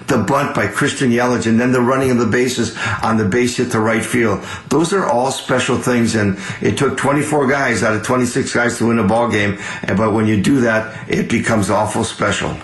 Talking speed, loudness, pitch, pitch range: 225 wpm, -16 LUFS, 120 Hz, 110-125 Hz